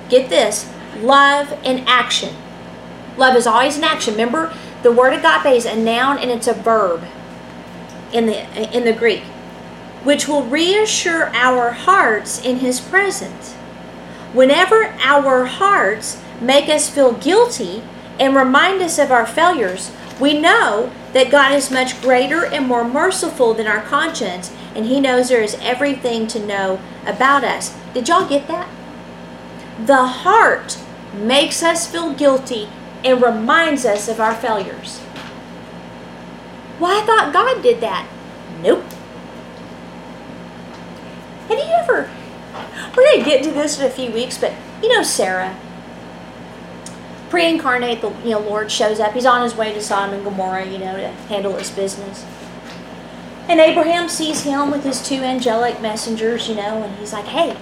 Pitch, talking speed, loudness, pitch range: 255 Hz, 155 wpm, -16 LUFS, 225-300 Hz